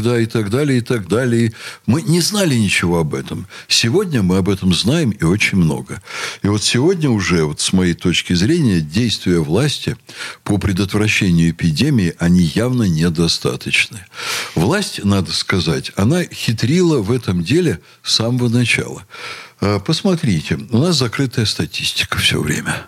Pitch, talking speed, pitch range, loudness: 110 Hz, 145 wpm, 90-125 Hz, -16 LUFS